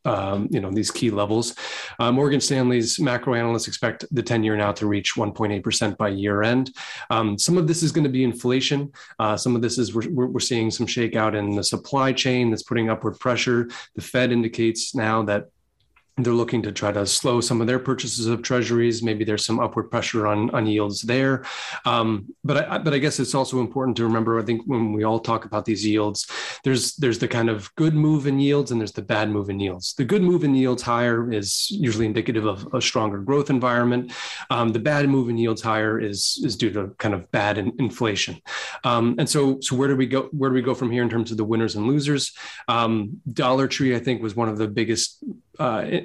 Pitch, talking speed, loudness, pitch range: 115 Hz, 225 wpm, -22 LUFS, 110-130 Hz